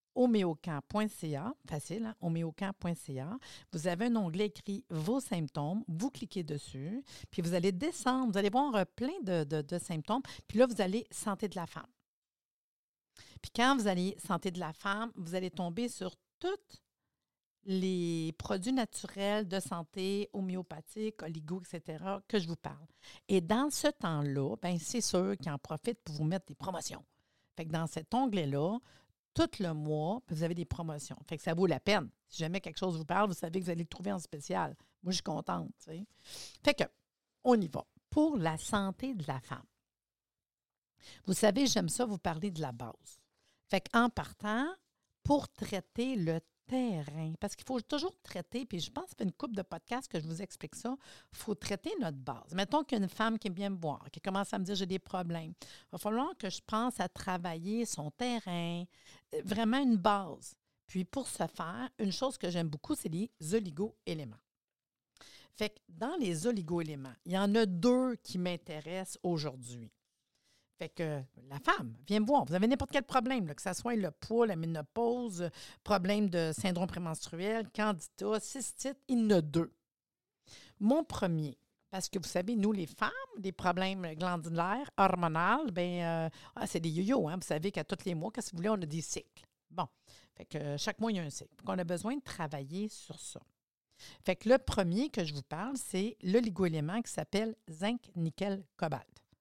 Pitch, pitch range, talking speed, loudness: 190 Hz, 165-220 Hz, 195 wpm, -35 LUFS